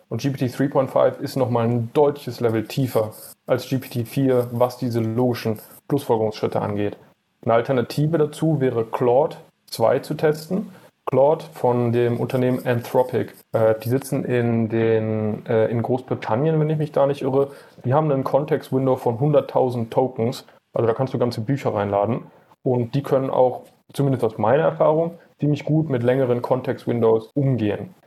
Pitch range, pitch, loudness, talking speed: 115-140 Hz, 125 Hz, -21 LUFS, 155 wpm